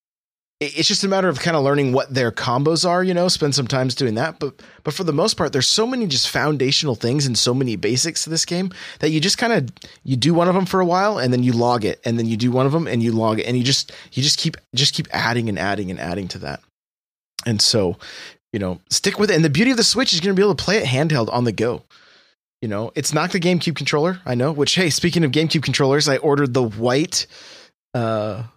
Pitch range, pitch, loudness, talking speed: 125-170 Hz, 145 Hz, -19 LUFS, 265 wpm